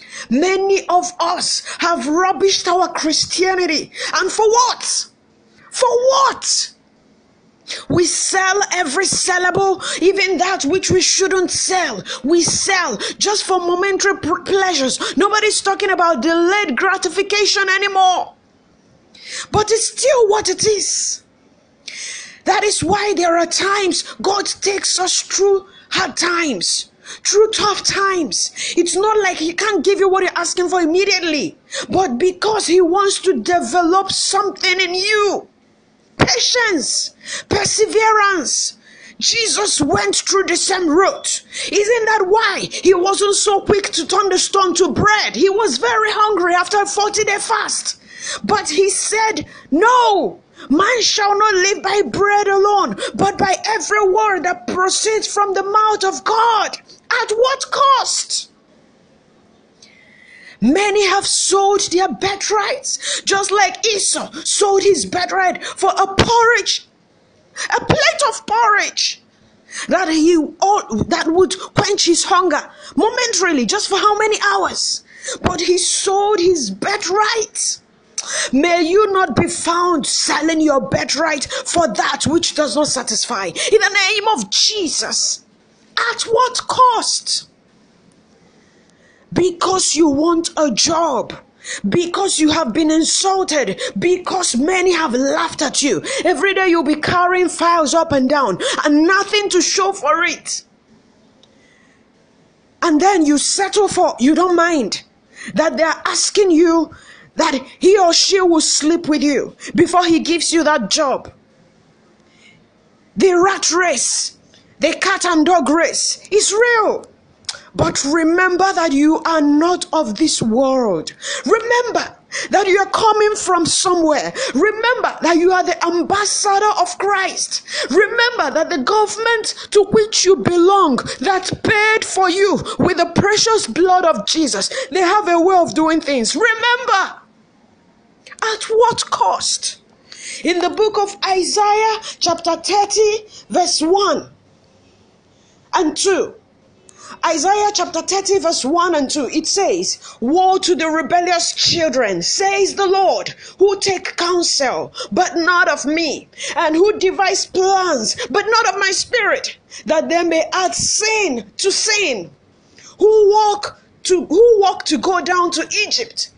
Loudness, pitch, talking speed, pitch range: -15 LUFS, 370 Hz, 135 wpm, 330-405 Hz